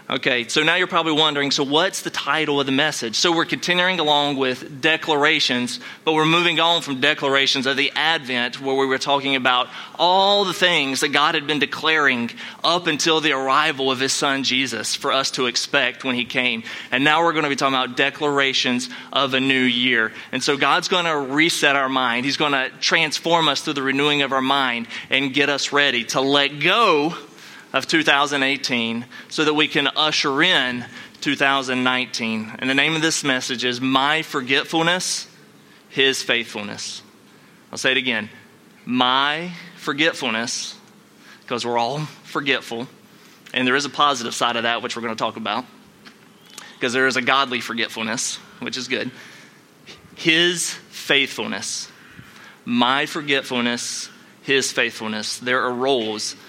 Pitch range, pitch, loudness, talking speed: 125-155 Hz, 140 Hz, -19 LUFS, 165 wpm